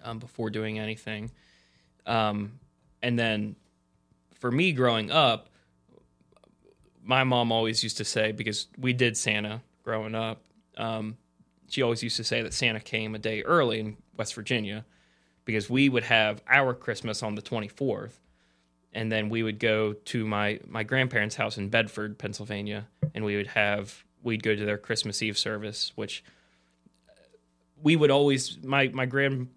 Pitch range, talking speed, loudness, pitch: 105-120 Hz, 160 wpm, -27 LUFS, 110 Hz